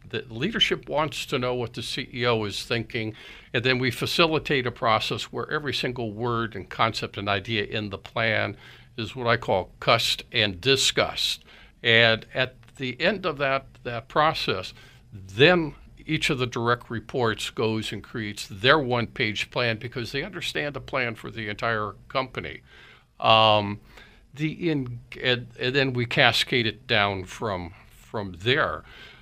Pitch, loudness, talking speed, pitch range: 120 Hz, -25 LUFS, 155 wpm, 110-130 Hz